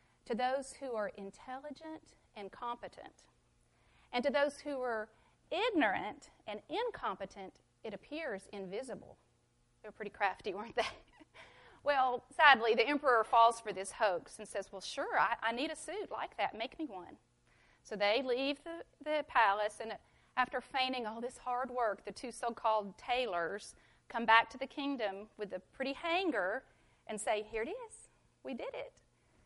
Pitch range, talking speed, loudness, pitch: 210-280 Hz, 165 wpm, -35 LUFS, 245 Hz